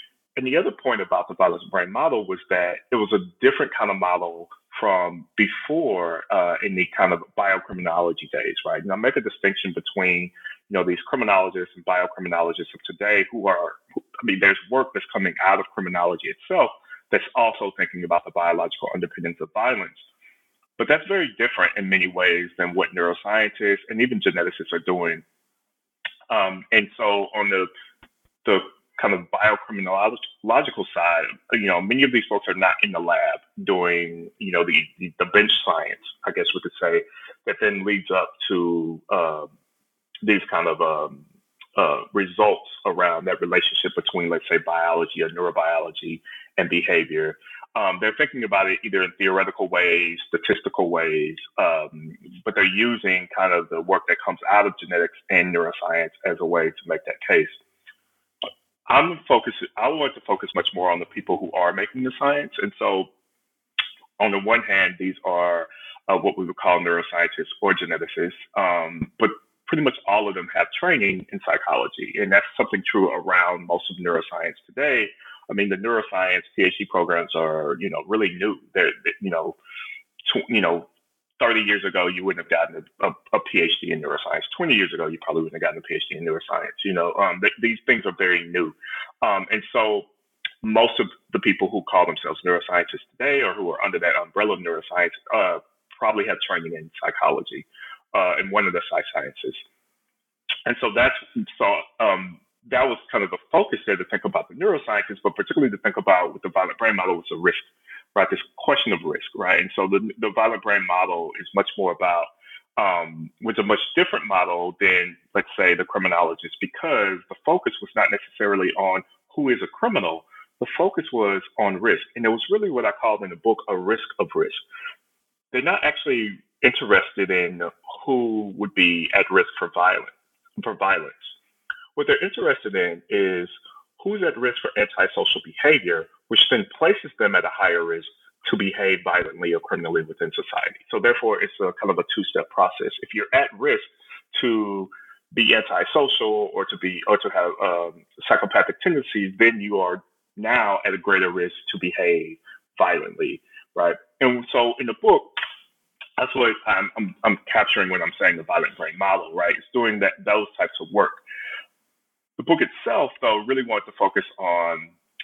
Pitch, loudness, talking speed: 120 Hz, -22 LUFS, 185 wpm